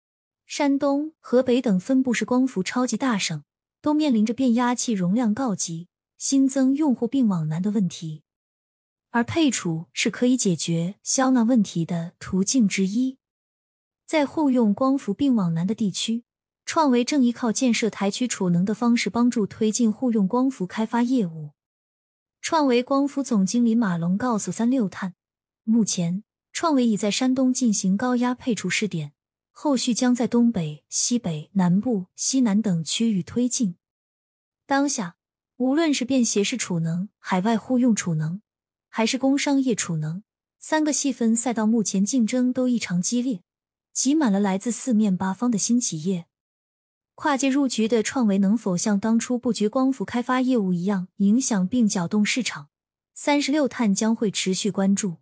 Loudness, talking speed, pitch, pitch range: -23 LUFS, 245 characters per minute, 230 Hz, 190-250 Hz